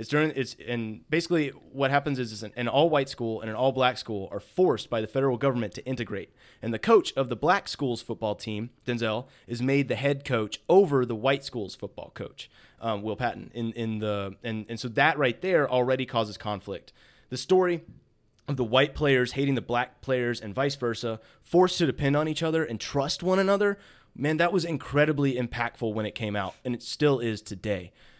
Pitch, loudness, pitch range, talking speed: 125 Hz, -27 LUFS, 115-140 Hz, 210 wpm